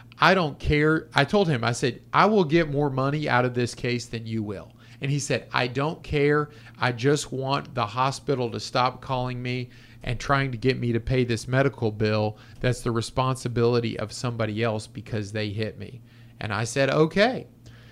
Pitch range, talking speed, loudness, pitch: 115-140 Hz, 200 wpm, -25 LUFS, 125 Hz